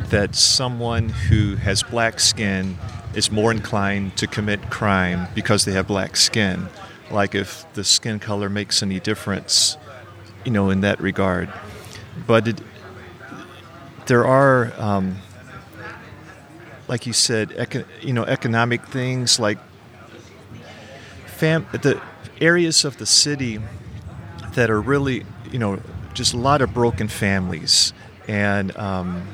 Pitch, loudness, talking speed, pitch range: 110 Hz, -19 LUFS, 130 wpm, 100-120 Hz